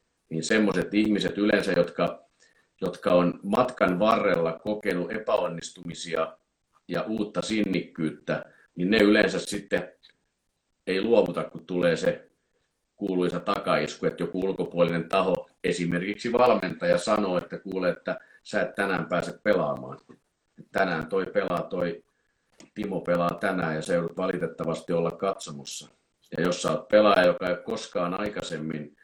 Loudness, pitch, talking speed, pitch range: -26 LUFS, 85 Hz, 130 wpm, 80-100 Hz